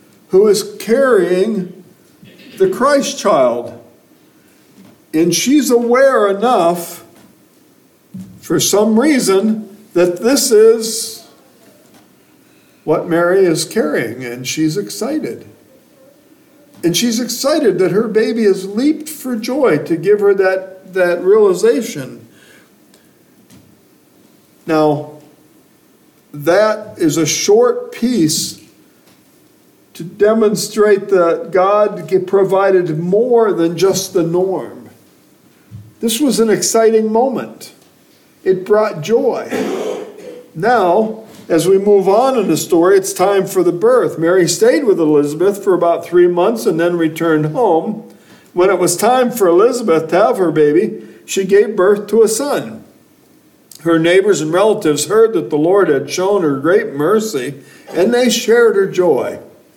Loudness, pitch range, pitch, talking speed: -13 LUFS, 175-250 Hz, 205 Hz, 120 wpm